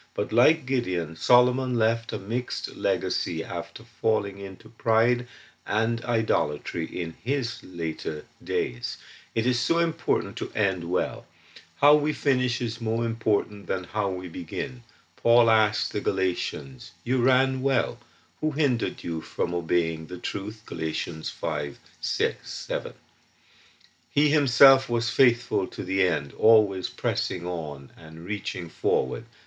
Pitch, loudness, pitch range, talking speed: 115 Hz, -26 LUFS, 90-125 Hz, 135 wpm